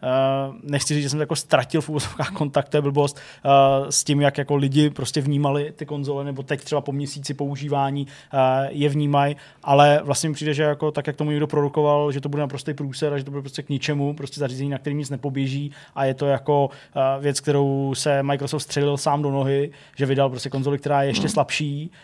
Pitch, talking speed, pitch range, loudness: 145 Hz, 220 wpm, 140-150 Hz, -22 LUFS